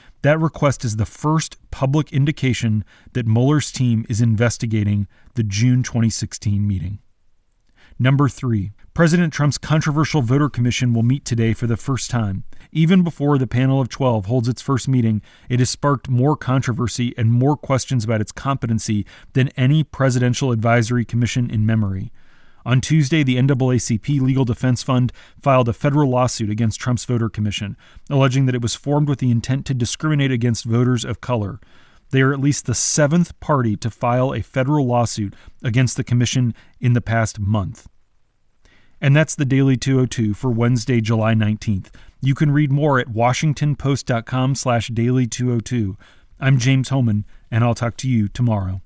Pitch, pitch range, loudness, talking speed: 125 Hz, 110-135 Hz, -19 LUFS, 160 wpm